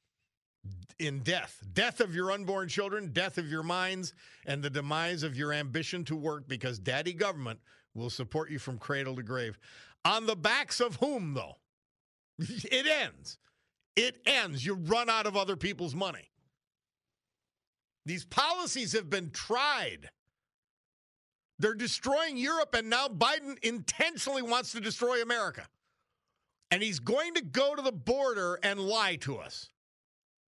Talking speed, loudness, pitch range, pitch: 145 wpm, -32 LUFS, 155-240 Hz, 190 Hz